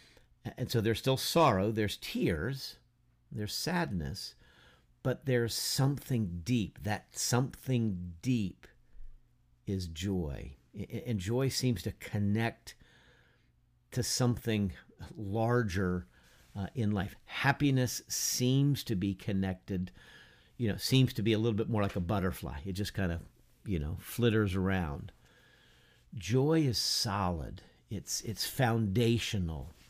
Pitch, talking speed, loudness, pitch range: 110 Hz, 120 wpm, -33 LUFS, 95-125 Hz